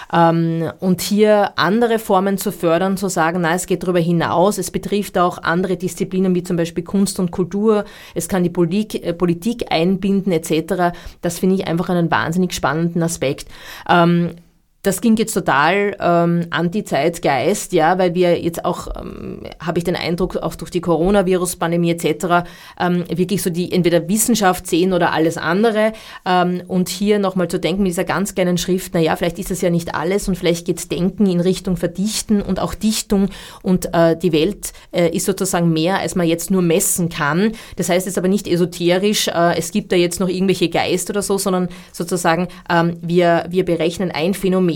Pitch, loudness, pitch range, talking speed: 180 Hz, -18 LUFS, 170-195 Hz, 190 wpm